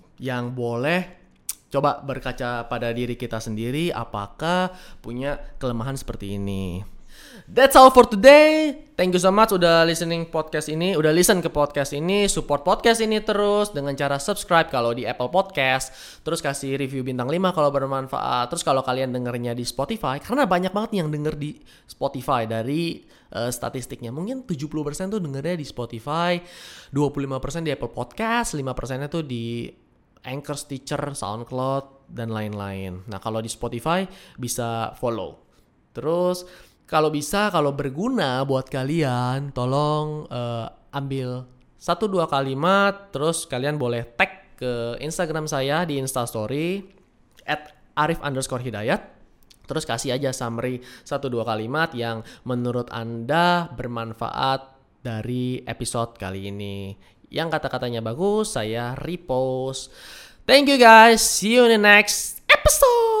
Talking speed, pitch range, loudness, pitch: 135 wpm, 120-170 Hz, -22 LUFS, 140 Hz